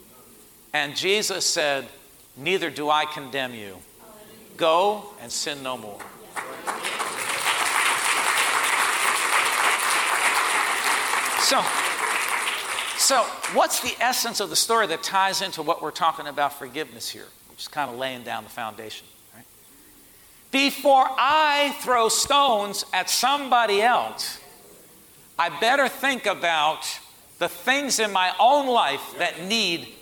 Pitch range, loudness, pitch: 145-230 Hz, -22 LUFS, 185 Hz